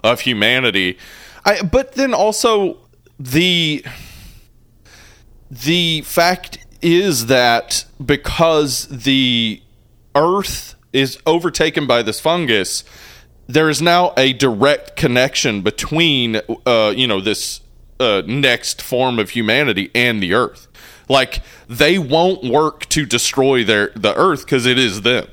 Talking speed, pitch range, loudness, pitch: 120 wpm, 115-160 Hz, -15 LUFS, 135 Hz